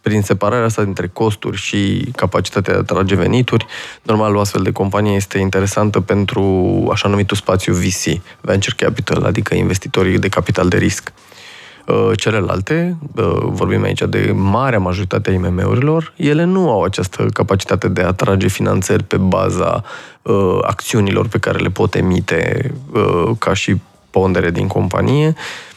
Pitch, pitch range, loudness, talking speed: 100 Hz, 95-115 Hz, -16 LUFS, 140 wpm